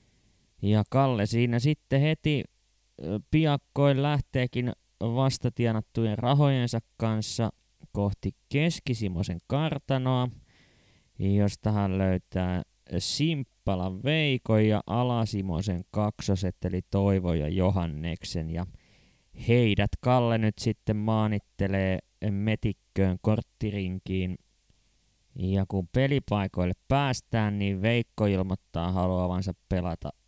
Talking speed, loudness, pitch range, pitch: 85 wpm, -28 LUFS, 95-125 Hz, 105 Hz